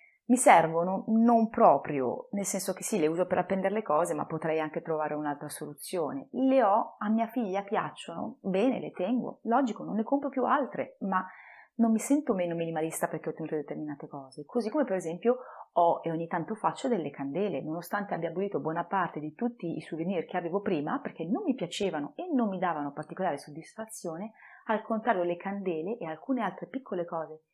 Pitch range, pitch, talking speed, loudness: 160-230 Hz, 190 Hz, 190 wpm, -30 LUFS